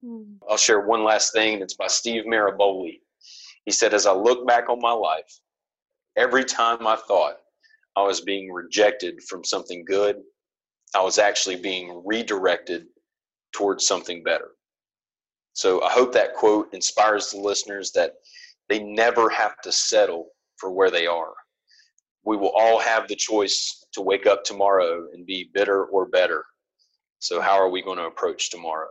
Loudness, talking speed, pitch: -22 LUFS, 160 wpm, 110 Hz